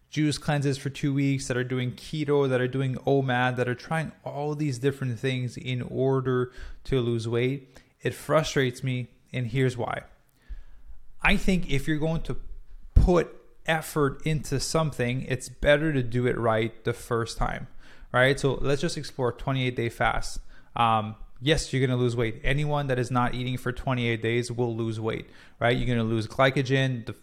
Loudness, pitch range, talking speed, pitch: -27 LUFS, 120-140 Hz, 185 wpm, 130 Hz